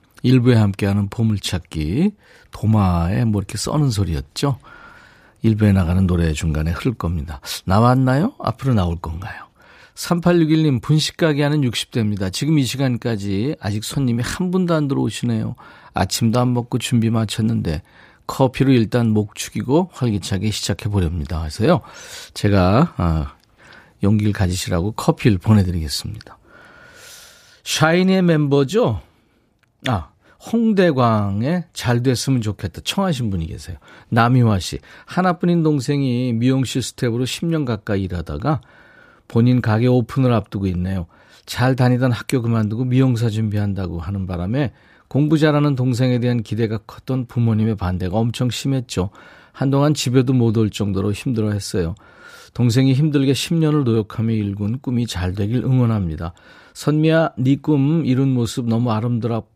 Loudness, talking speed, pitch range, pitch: -19 LUFS, 315 characters per minute, 100-135 Hz, 115 Hz